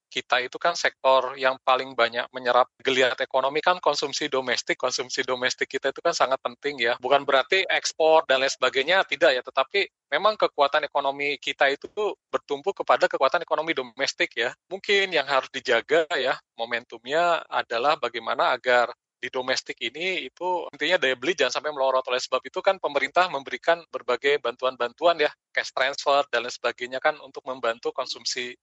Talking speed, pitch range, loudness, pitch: 165 wpm, 130-165 Hz, -24 LUFS, 135 Hz